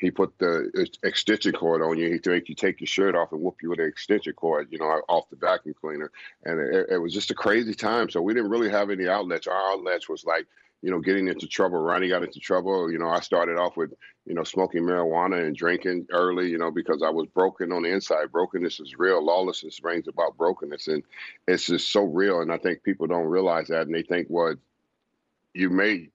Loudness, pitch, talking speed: -25 LUFS, 90 Hz, 230 wpm